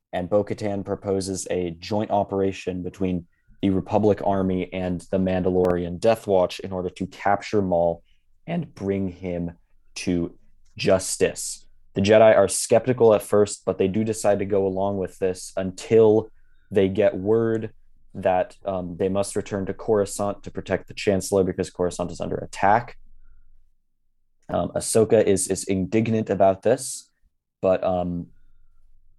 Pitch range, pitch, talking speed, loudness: 90-100 Hz, 95 Hz, 140 wpm, -23 LUFS